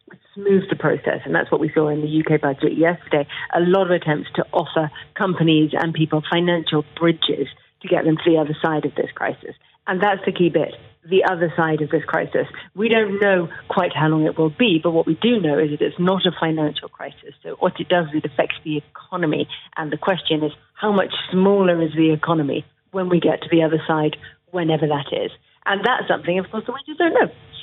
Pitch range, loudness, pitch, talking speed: 155-180 Hz, -20 LUFS, 165 Hz, 230 wpm